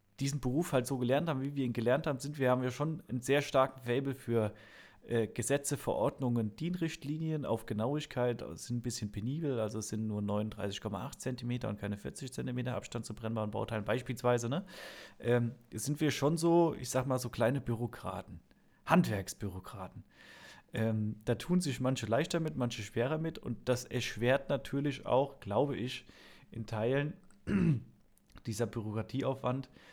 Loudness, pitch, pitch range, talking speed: -35 LUFS, 125 Hz, 110-140 Hz, 160 wpm